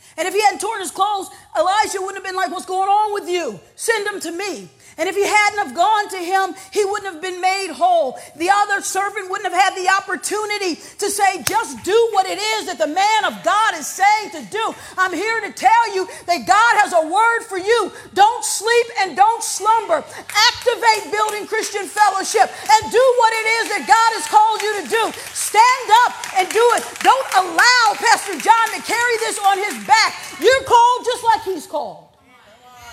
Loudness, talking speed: -17 LUFS, 205 wpm